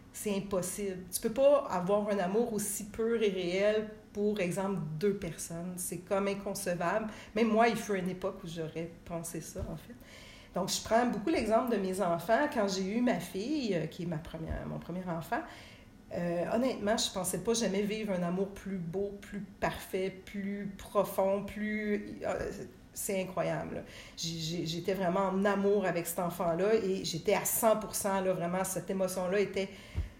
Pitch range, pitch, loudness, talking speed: 175-210 Hz, 195 Hz, -33 LUFS, 175 wpm